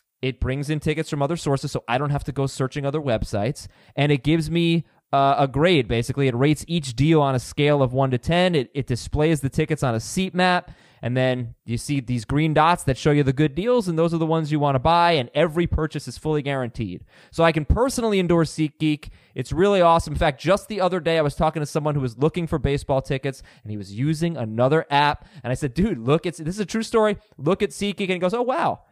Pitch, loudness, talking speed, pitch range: 150 Hz, -22 LUFS, 255 wpm, 135-170 Hz